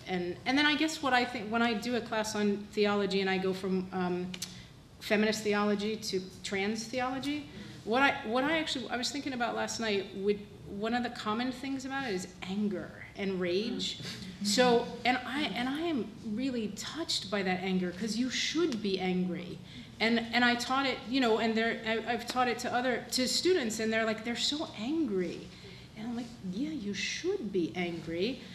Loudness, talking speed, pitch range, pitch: -32 LUFS, 200 wpm, 195-250 Hz, 225 Hz